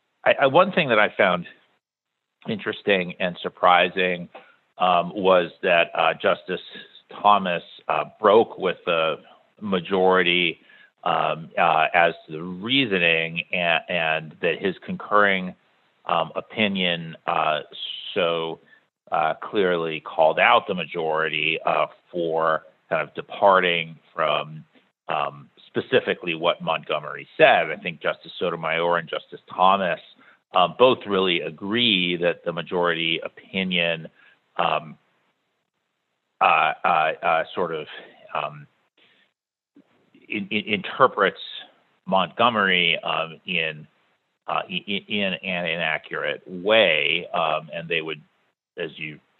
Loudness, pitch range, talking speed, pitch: -22 LUFS, 80-95 Hz, 110 wpm, 85 Hz